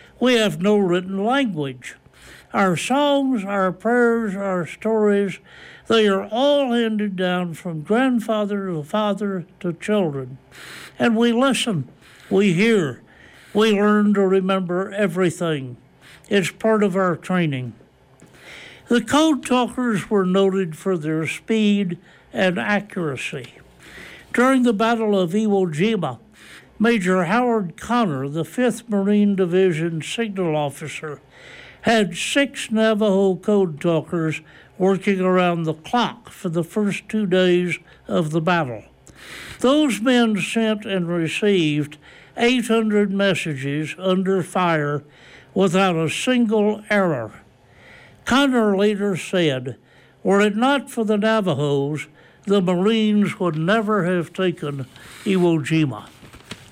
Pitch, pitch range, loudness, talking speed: 195 Hz, 170-220 Hz, -20 LUFS, 115 wpm